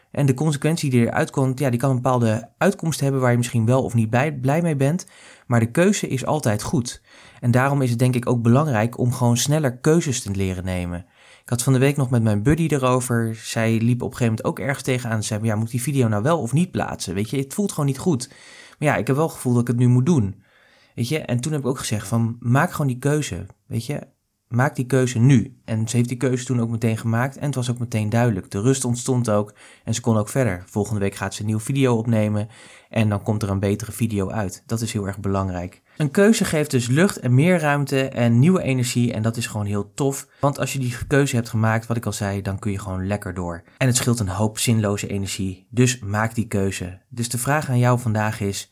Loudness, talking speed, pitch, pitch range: -21 LUFS, 260 wpm, 120 Hz, 105-135 Hz